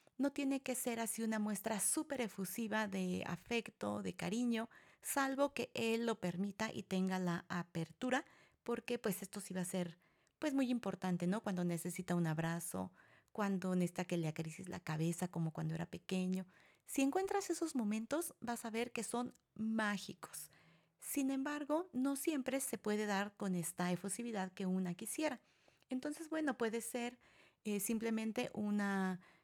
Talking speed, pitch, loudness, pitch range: 160 wpm, 210 Hz, -40 LUFS, 180-245 Hz